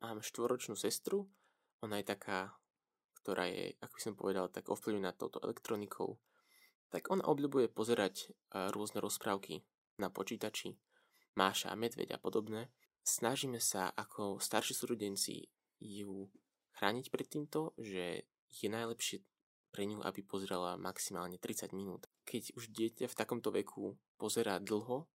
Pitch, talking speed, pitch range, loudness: 105 Hz, 130 wpm, 100-120 Hz, -40 LUFS